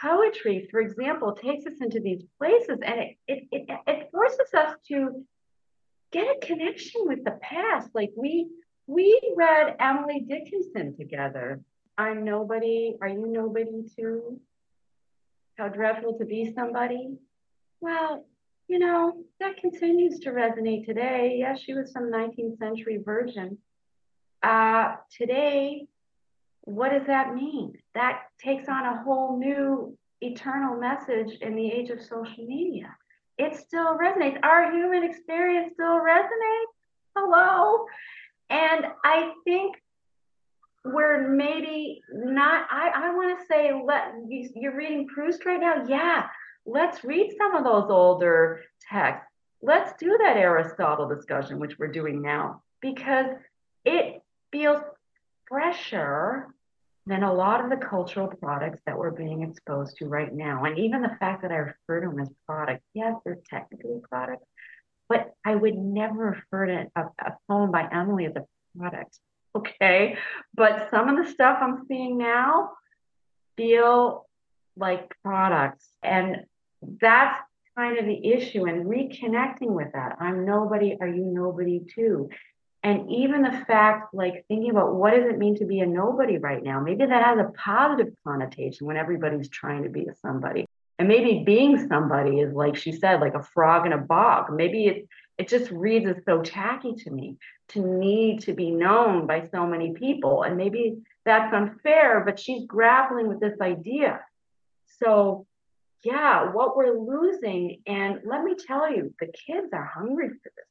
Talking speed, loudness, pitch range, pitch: 155 wpm, -25 LUFS, 195-285 Hz, 230 Hz